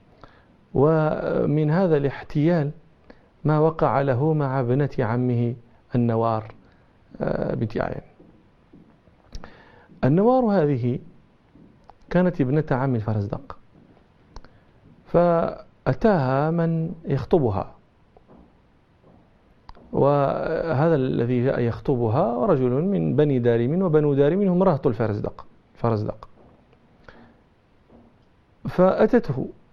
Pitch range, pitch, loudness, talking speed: 125-165 Hz, 145 Hz, -22 LUFS, 70 wpm